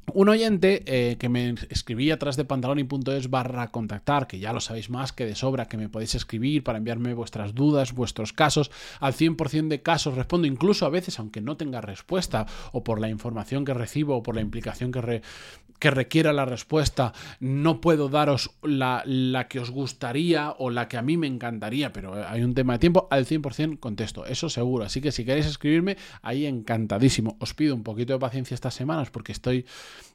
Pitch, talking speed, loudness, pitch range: 130 Hz, 200 wpm, -26 LUFS, 120-150 Hz